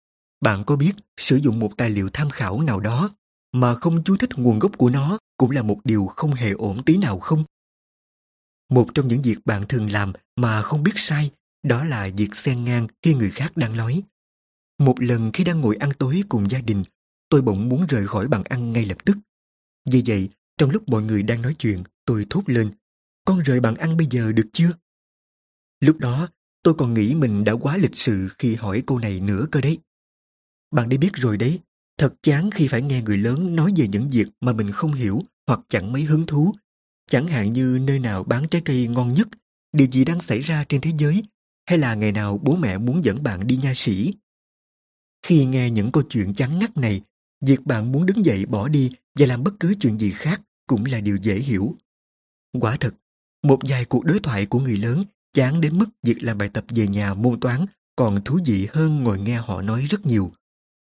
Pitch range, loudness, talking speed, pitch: 110-155 Hz, -21 LUFS, 220 wpm, 130 Hz